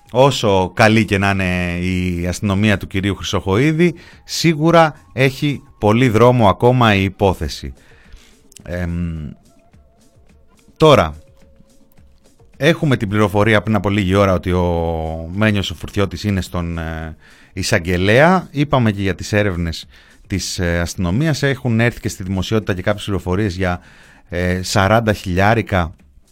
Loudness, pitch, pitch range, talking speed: -16 LUFS, 100 Hz, 90-110 Hz, 120 wpm